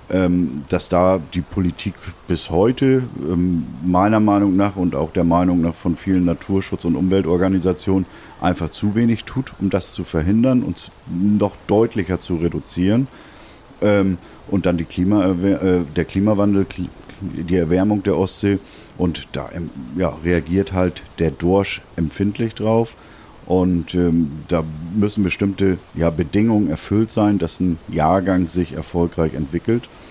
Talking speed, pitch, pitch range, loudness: 130 wpm, 90 Hz, 85-100 Hz, -19 LUFS